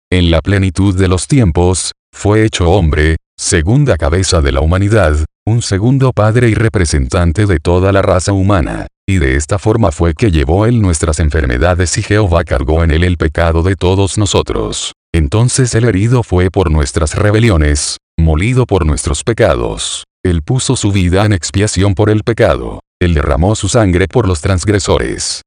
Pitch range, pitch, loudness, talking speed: 85-105 Hz, 95 Hz, -12 LUFS, 165 wpm